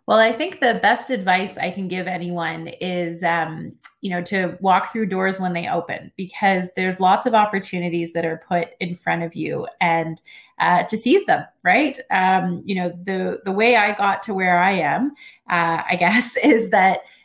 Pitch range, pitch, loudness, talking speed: 175-210 Hz, 185 Hz, -20 LUFS, 195 wpm